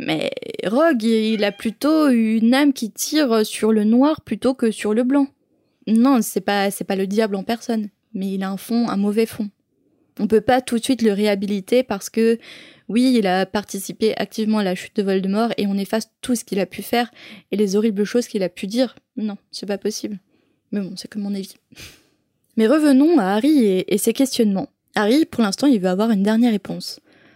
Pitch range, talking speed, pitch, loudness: 205-245 Hz, 215 wpm, 220 Hz, -20 LUFS